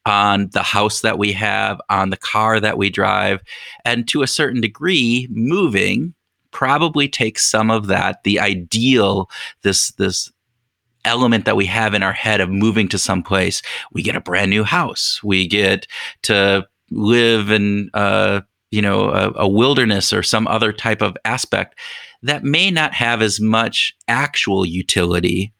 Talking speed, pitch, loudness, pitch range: 165 wpm, 105 Hz, -16 LUFS, 100-115 Hz